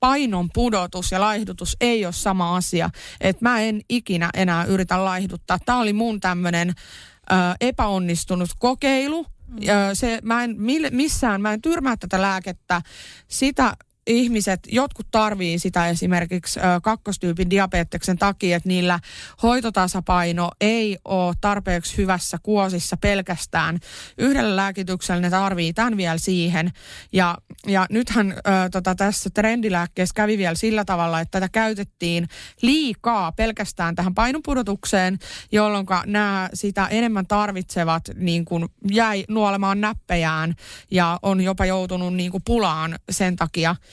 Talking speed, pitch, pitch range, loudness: 125 wpm, 190 Hz, 180-220 Hz, -21 LUFS